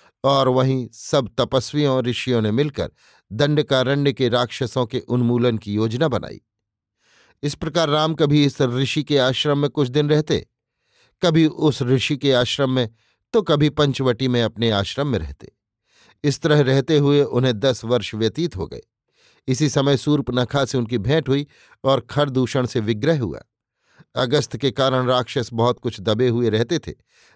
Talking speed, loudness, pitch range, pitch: 160 wpm, -20 LUFS, 120-145 Hz, 130 Hz